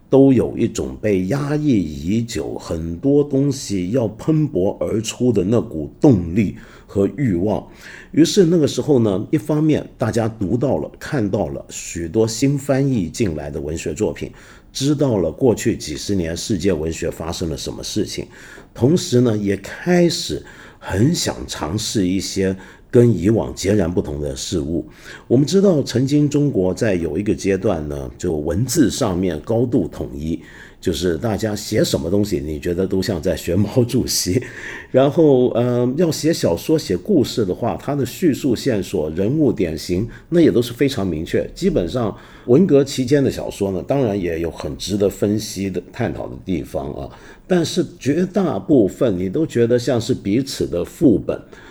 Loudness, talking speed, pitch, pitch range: -19 LUFS, 250 characters per minute, 110 Hz, 95-140 Hz